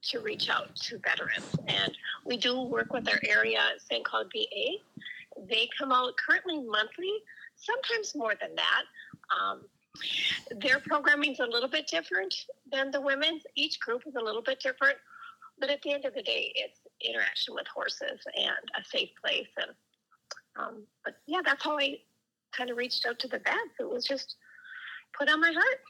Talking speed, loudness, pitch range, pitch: 180 wpm, -30 LUFS, 260-440 Hz, 300 Hz